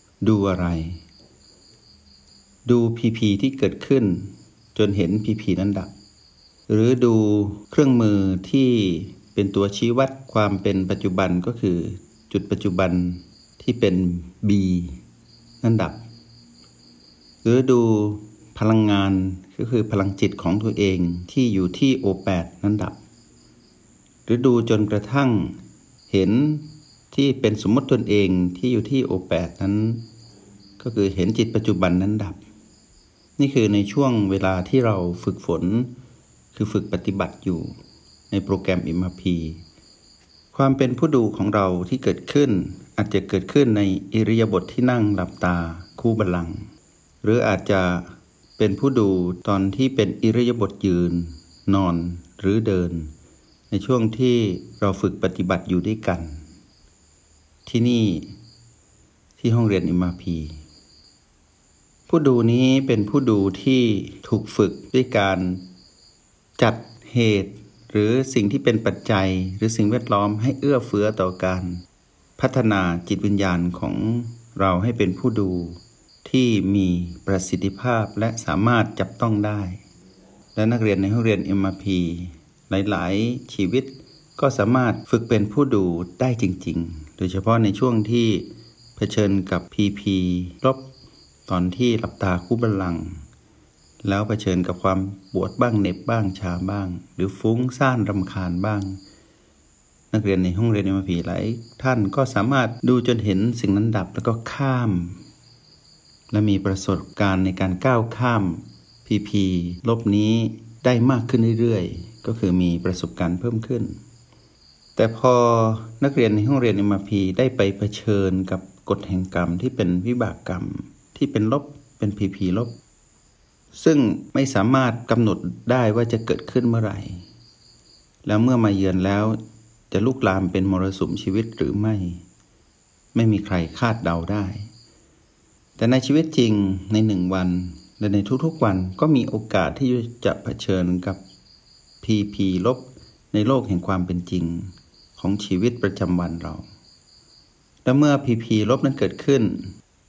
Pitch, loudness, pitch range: 100 Hz, -21 LUFS, 95-115 Hz